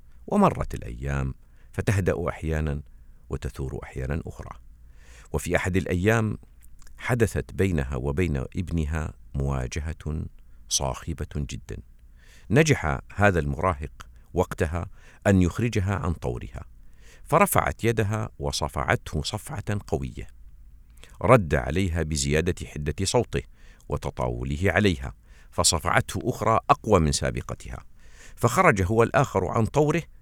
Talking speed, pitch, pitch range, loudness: 95 wpm, 75 Hz, 65-95 Hz, -25 LUFS